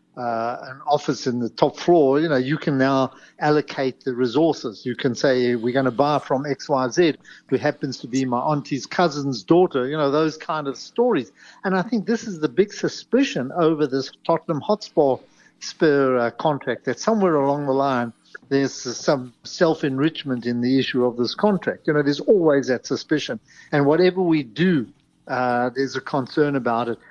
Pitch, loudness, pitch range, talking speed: 140 Hz, -21 LUFS, 130-160 Hz, 185 wpm